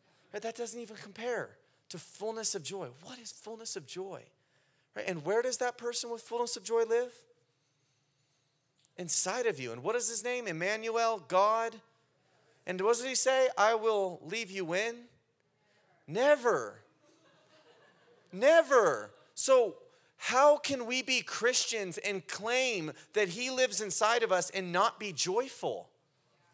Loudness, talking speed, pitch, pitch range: -31 LUFS, 145 wpm, 225 Hz, 185-245 Hz